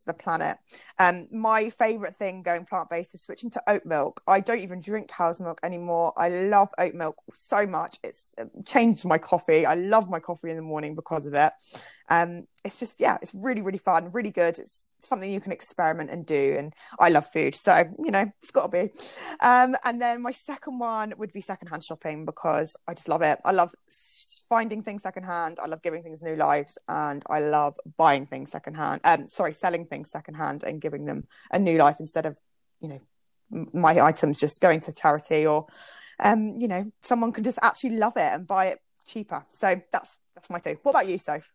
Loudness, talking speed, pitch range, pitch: -25 LUFS, 210 wpm, 160-220 Hz, 180 Hz